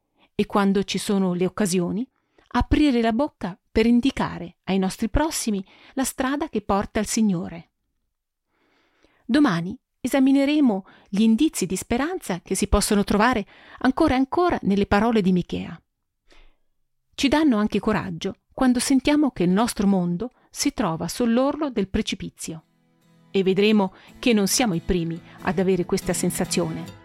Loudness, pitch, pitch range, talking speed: -22 LUFS, 210 Hz, 185-255 Hz, 140 wpm